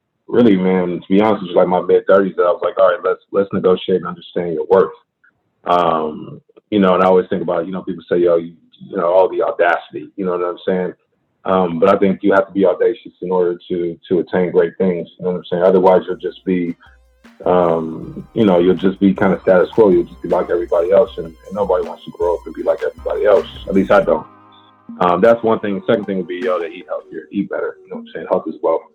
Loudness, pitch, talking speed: -16 LUFS, 95 Hz, 265 wpm